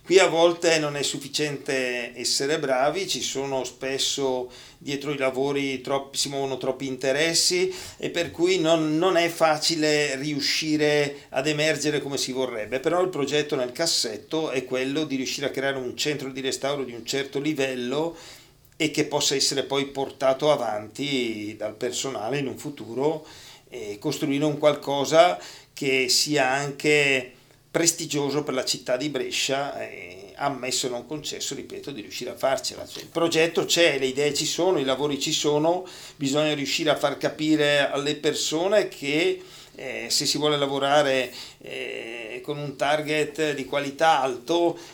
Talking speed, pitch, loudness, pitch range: 160 wpm, 145 Hz, -24 LUFS, 135-155 Hz